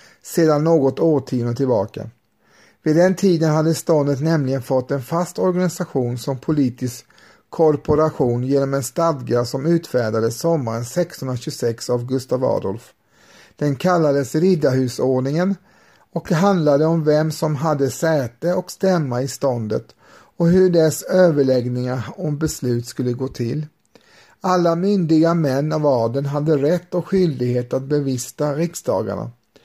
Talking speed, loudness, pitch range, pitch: 125 wpm, -19 LUFS, 130-165 Hz, 150 Hz